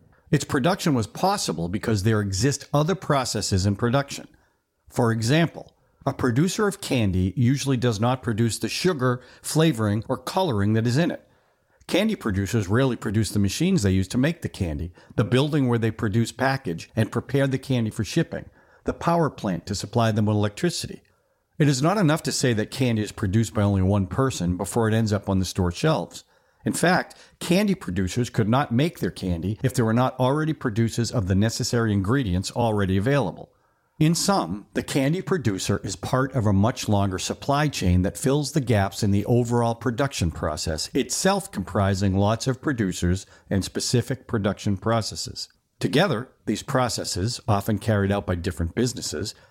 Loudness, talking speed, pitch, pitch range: -24 LUFS, 175 wpm, 115 Hz, 100-135 Hz